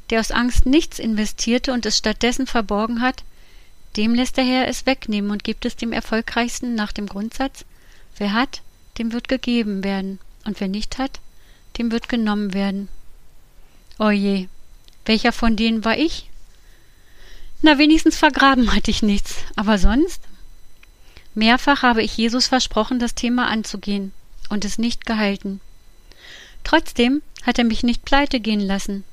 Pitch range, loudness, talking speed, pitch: 210-250 Hz, -20 LUFS, 150 wpm, 230 Hz